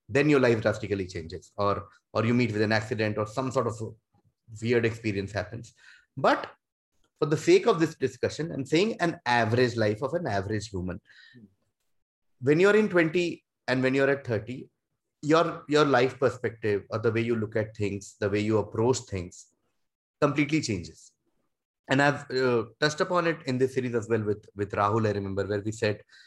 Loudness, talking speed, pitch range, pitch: -27 LUFS, 190 wpm, 105-140 Hz, 115 Hz